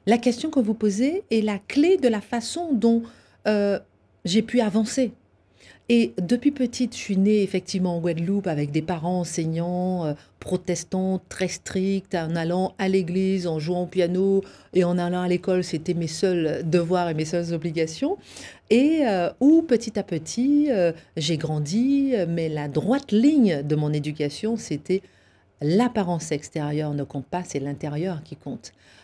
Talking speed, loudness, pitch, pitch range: 165 wpm, -24 LUFS, 185 Hz, 165-220 Hz